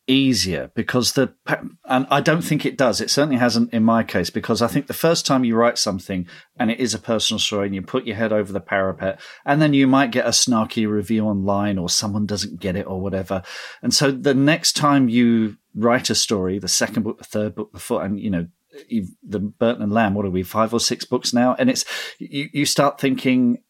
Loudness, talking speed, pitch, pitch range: -20 LUFS, 235 wpm, 115 Hz, 100-135 Hz